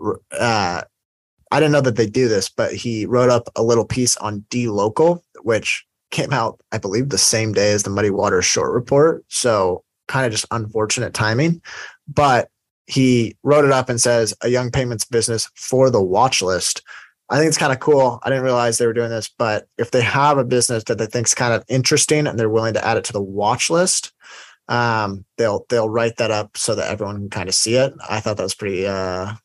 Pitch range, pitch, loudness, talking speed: 110-130 Hz, 120 Hz, -18 LUFS, 220 wpm